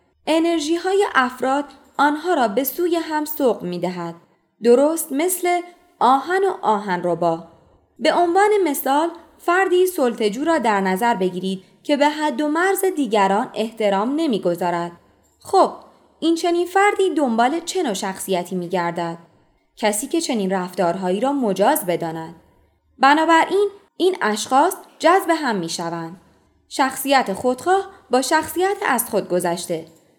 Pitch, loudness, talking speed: 270 Hz, -19 LUFS, 130 wpm